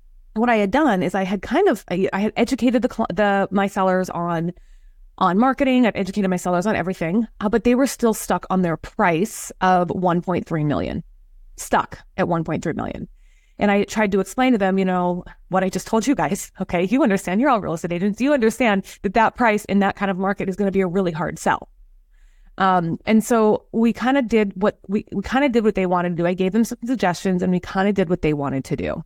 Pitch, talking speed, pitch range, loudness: 195 Hz, 235 wpm, 180-225 Hz, -20 LUFS